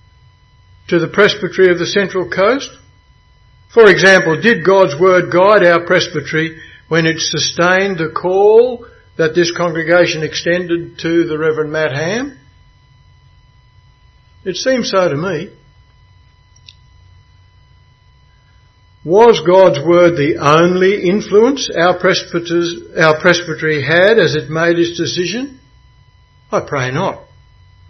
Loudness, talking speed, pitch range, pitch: -12 LUFS, 115 wpm, 155-185 Hz, 170 Hz